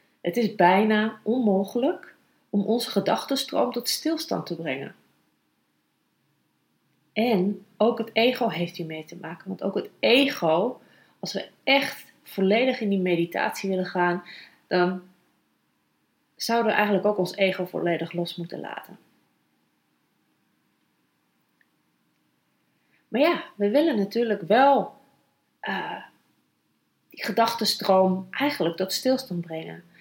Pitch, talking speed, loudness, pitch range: 200 Hz, 115 wpm, -24 LUFS, 180-235 Hz